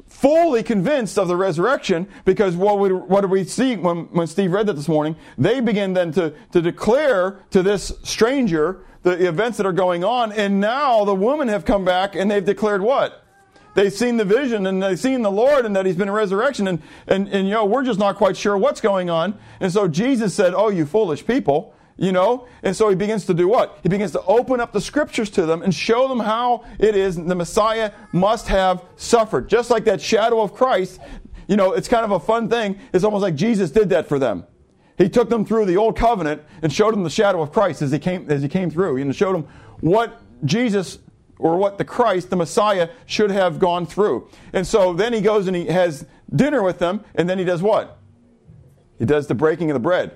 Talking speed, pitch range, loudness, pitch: 230 wpm, 180-220 Hz, -19 LUFS, 195 Hz